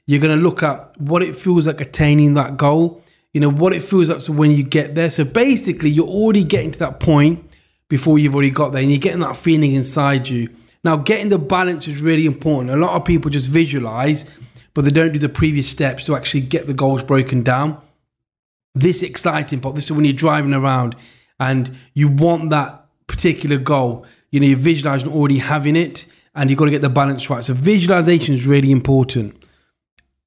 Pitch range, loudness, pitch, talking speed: 135-165 Hz, -16 LUFS, 150 Hz, 210 wpm